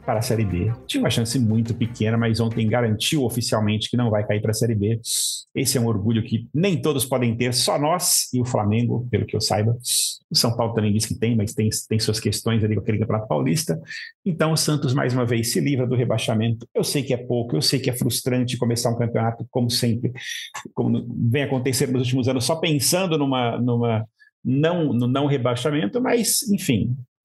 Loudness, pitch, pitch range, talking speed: -22 LUFS, 120 Hz, 115-135 Hz, 215 wpm